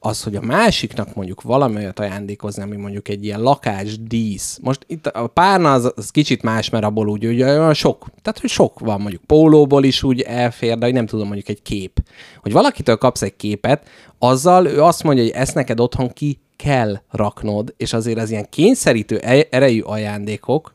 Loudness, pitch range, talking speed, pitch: -17 LUFS, 105-135 Hz, 190 wpm, 115 Hz